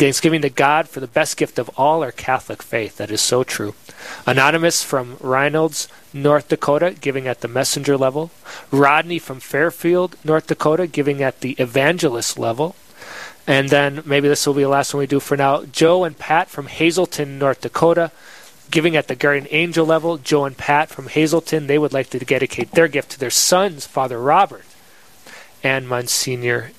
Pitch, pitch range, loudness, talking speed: 145 Hz, 135-160 Hz, -18 LUFS, 180 wpm